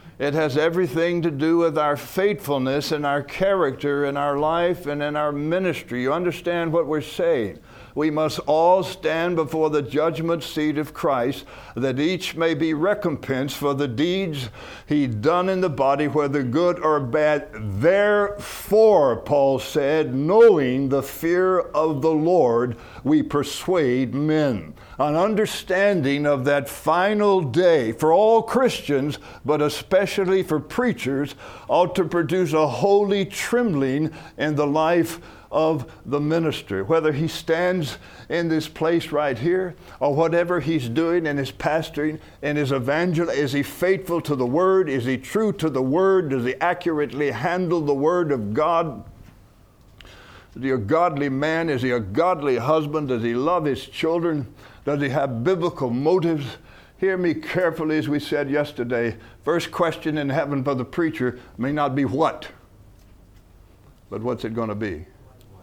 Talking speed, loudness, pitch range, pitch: 155 wpm, -22 LUFS, 135-170 Hz, 150 Hz